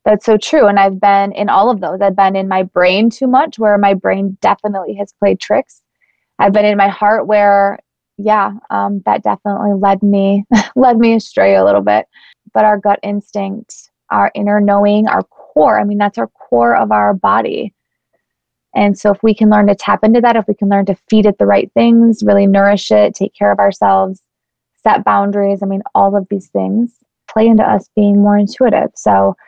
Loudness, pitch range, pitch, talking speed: -12 LUFS, 195-210 Hz, 200 Hz, 205 wpm